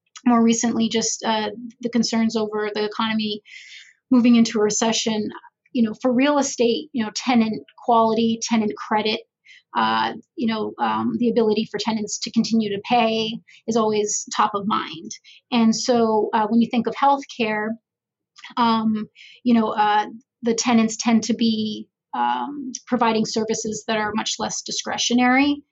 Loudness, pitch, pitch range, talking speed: -21 LUFS, 225 Hz, 215-240 Hz, 150 wpm